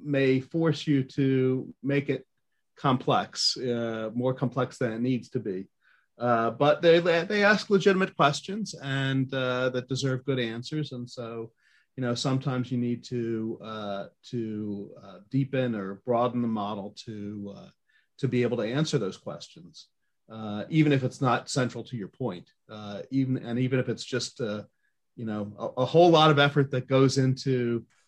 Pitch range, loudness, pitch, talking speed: 115-140 Hz, -27 LUFS, 130 Hz, 175 wpm